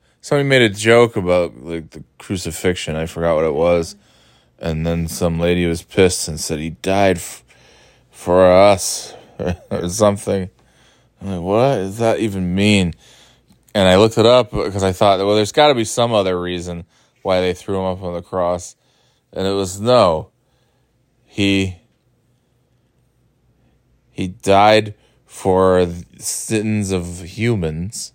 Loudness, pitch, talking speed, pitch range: -17 LUFS, 95 Hz, 155 wpm, 85-105 Hz